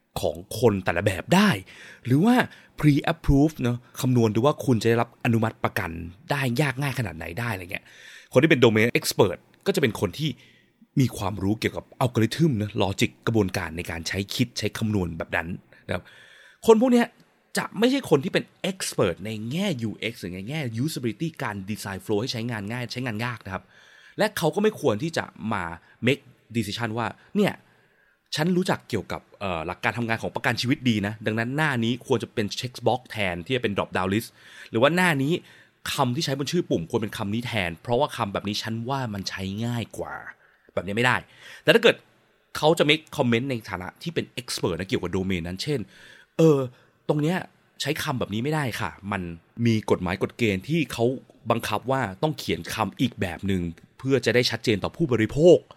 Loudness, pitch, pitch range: -25 LUFS, 115 Hz, 105-140 Hz